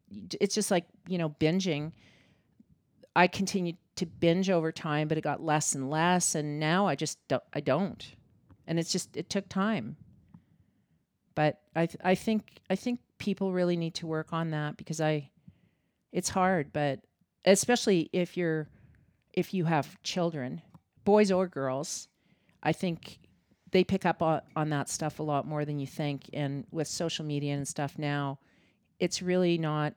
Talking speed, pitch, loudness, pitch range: 170 wpm, 165 Hz, -30 LUFS, 150-185 Hz